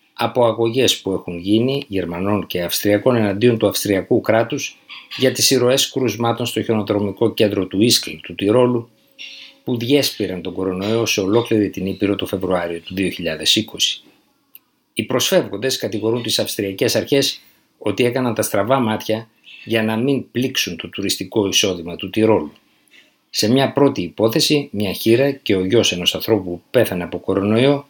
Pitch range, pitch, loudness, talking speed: 95-125 Hz, 110 Hz, -18 LUFS, 150 wpm